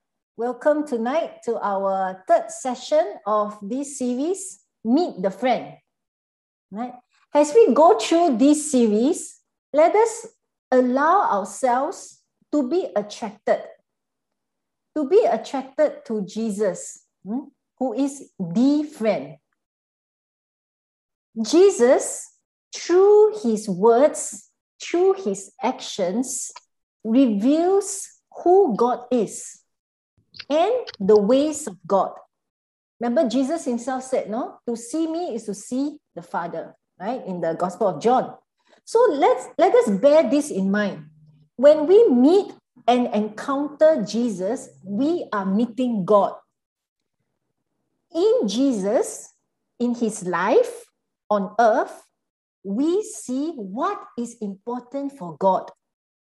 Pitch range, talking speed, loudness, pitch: 220-320 Hz, 110 wpm, -21 LUFS, 255 Hz